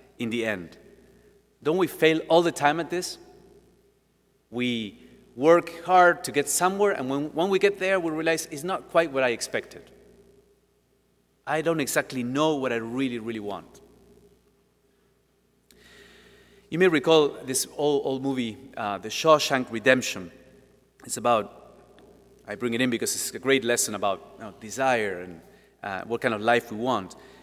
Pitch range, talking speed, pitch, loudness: 120-170 Hz, 160 wpm, 135 Hz, -25 LUFS